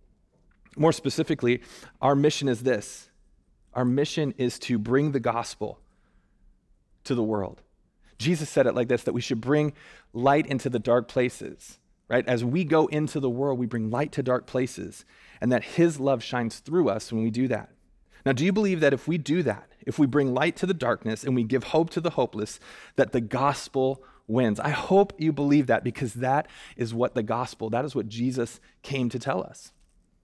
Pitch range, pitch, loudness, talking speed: 120-145 Hz, 130 Hz, -26 LUFS, 200 wpm